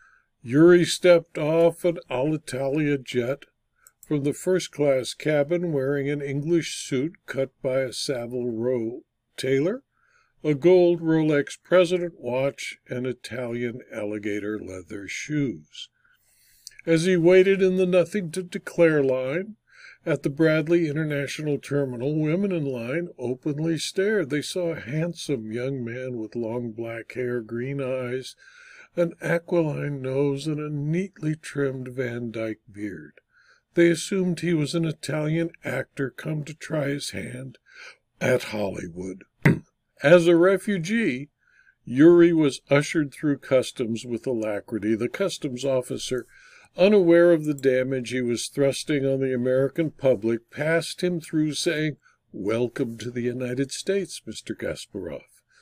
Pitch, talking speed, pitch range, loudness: 145 Hz, 130 wpm, 125-170 Hz, -24 LUFS